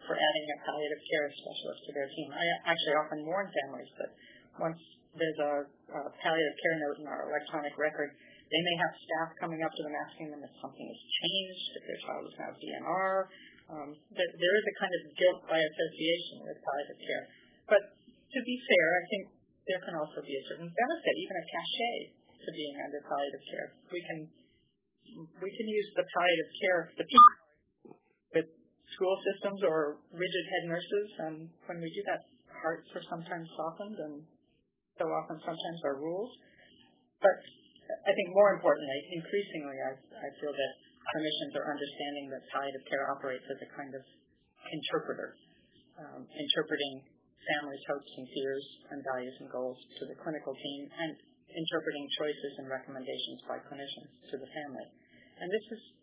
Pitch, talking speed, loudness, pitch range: 160 Hz, 170 wpm, -33 LUFS, 145-185 Hz